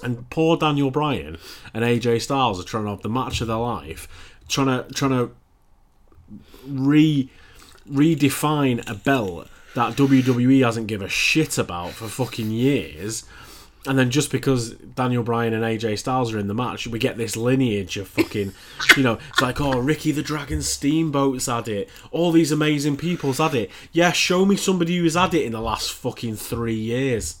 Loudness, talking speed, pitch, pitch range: -21 LUFS, 180 wpm, 125 Hz, 115-145 Hz